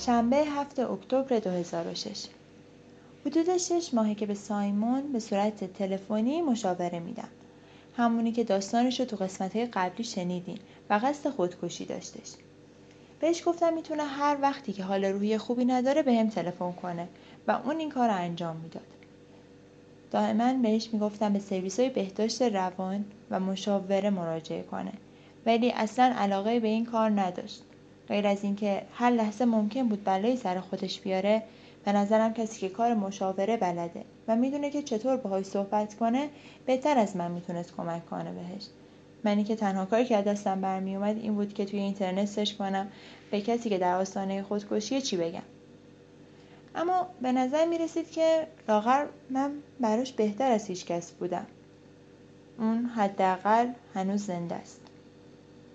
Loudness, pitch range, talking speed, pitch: -29 LUFS, 190-245 Hz, 150 wpm, 210 Hz